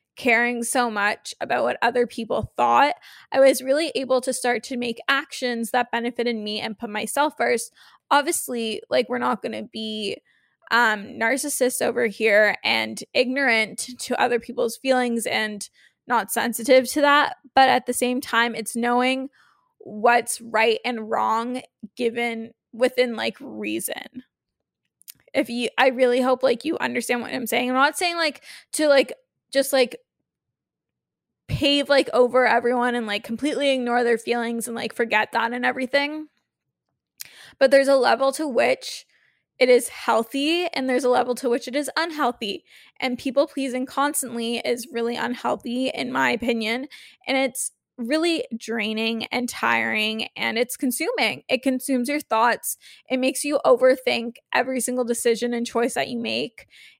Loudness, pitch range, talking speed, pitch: -22 LUFS, 235-270 Hz, 155 wpm, 245 Hz